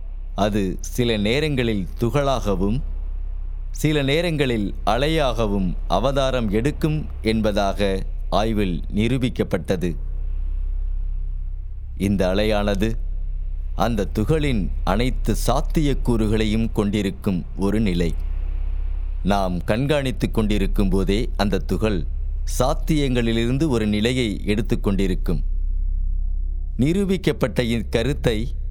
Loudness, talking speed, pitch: -23 LUFS, 70 wpm, 100 Hz